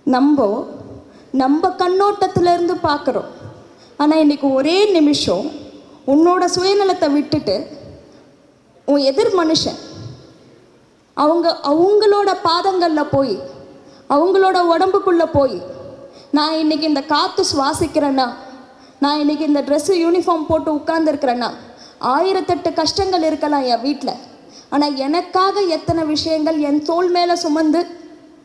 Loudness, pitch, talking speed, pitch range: -16 LUFS, 315 Hz, 95 wpm, 285-350 Hz